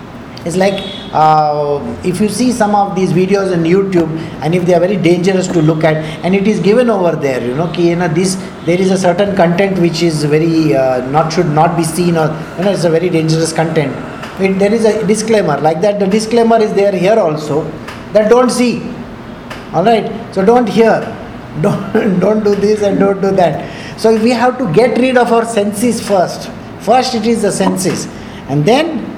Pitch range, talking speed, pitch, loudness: 165-215 Hz, 210 wpm, 190 Hz, -12 LUFS